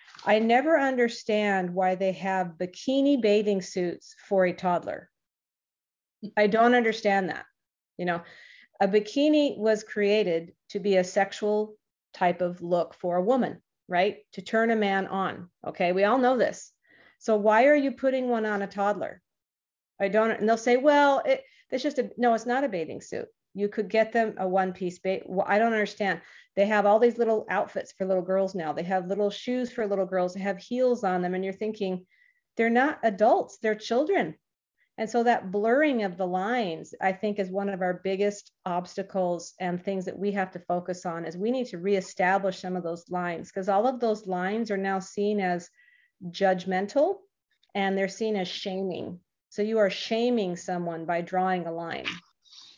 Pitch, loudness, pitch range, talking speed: 200 Hz, -27 LUFS, 185-225 Hz, 190 wpm